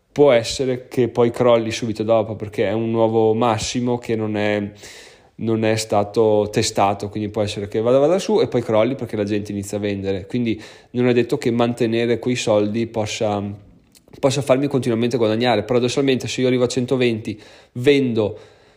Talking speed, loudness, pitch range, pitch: 175 wpm, -19 LUFS, 105-125 Hz, 115 Hz